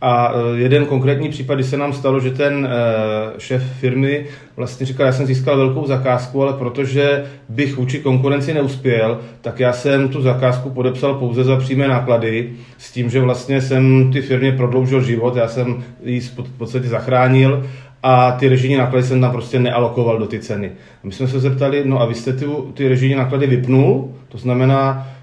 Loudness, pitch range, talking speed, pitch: -16 LUFS, 125-135 Hz, 185 wpm, 130 Hz